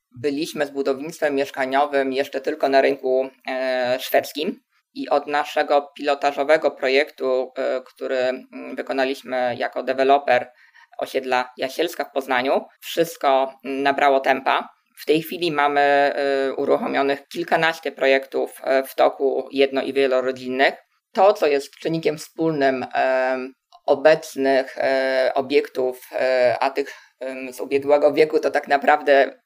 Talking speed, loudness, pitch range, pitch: 105 wpm, -21 LUFS, 130-145 Hz, 140 Hz